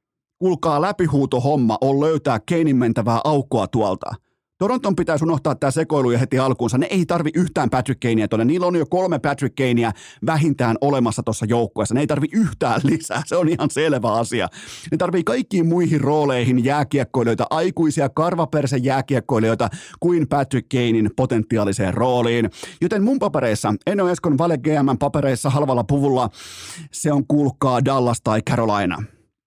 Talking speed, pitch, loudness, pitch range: 150 wpm, 140 Hz, -19 LUFS, 120-160 Hz